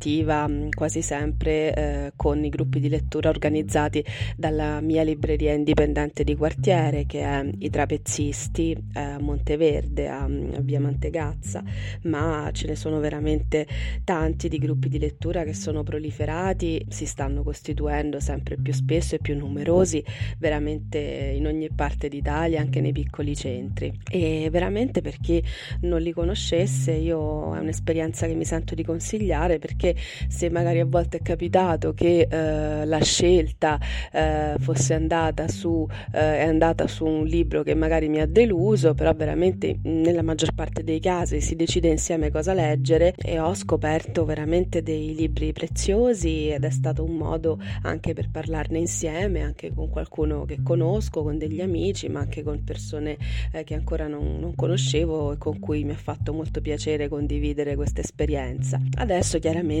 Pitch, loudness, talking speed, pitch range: 150 Hz, -25 LUFS, 160 wpm, 115-160 Hz